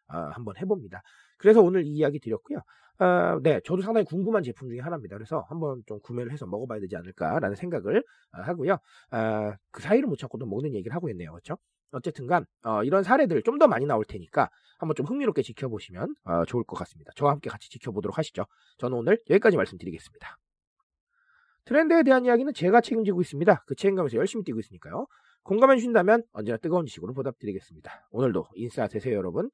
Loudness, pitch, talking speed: -26 LUFS, 150 Hz, 470 characters per minute